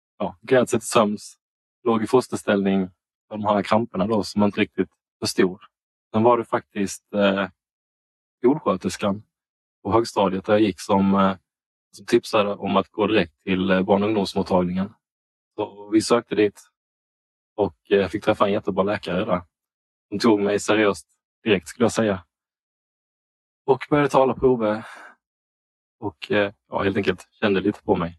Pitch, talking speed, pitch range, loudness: 100 Hz, 160 wpm, 95-110 Hz, -22 LUFS